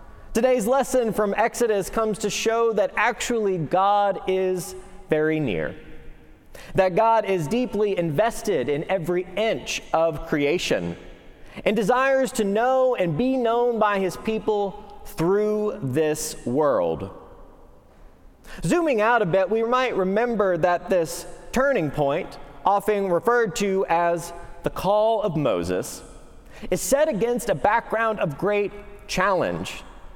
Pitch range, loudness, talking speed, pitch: 175-225 Hz, -23 LUFS, 125 wpm, 205 Hz